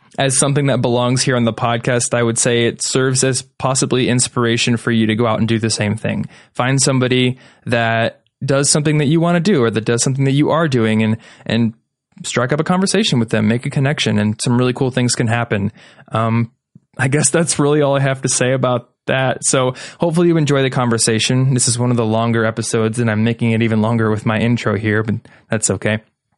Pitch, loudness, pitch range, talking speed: 125 Hz, -16 LUFS, 115-135 Hz, 225 wpm